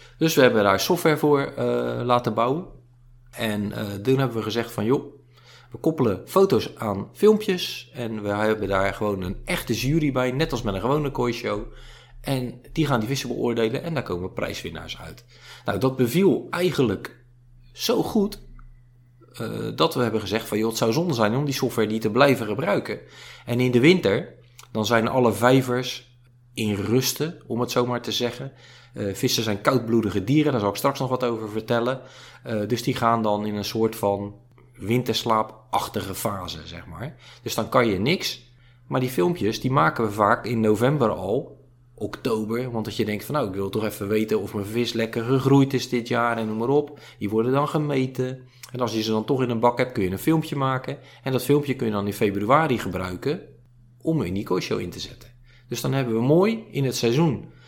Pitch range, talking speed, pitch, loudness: 110-130 Hz, 205 wpm, 120 Hz, -23 LUFS